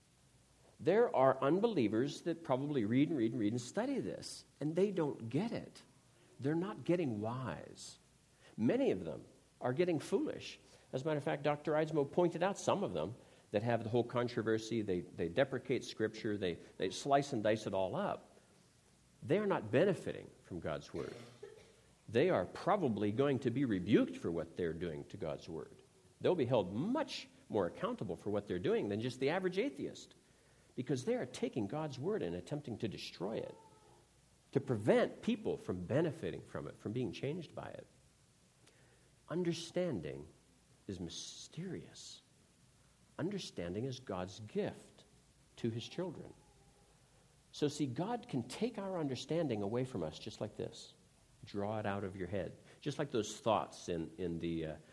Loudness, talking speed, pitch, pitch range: -38 LUFS, 165 wpm, 135 Hz, 110-170 Hz